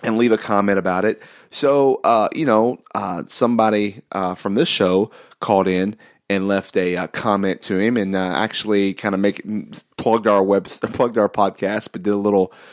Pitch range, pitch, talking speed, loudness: 95-110 Hz, 100 Hz, 200 wpm, -19 LUFS